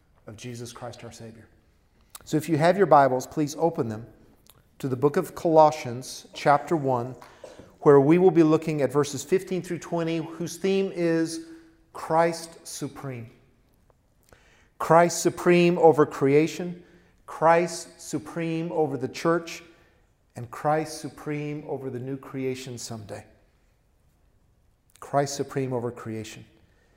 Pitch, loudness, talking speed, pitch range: 145 Hz, -24 LUFS, 125 wpm, 120-165 Hz